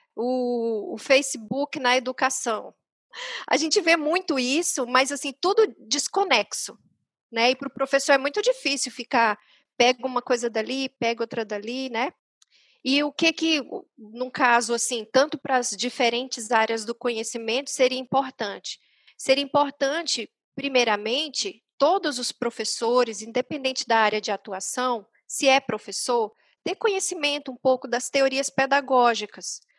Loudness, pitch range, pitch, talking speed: -24 LUFS, 235-280 Hz, 255 Hz, 135 wpm